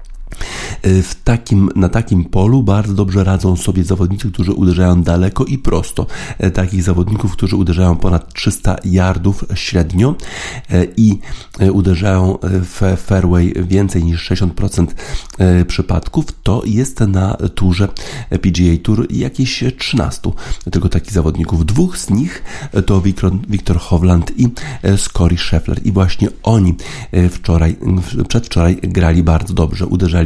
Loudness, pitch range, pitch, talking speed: -14 LUFS, 90-105 Hz, 95 Hz, 120 wpm